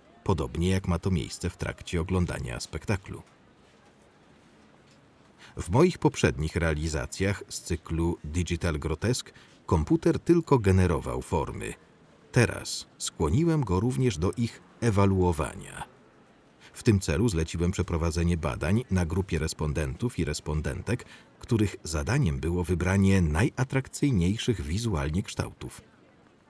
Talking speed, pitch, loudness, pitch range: 105 wpm, 90 Hz, -28 LUFS, 80-110 Hz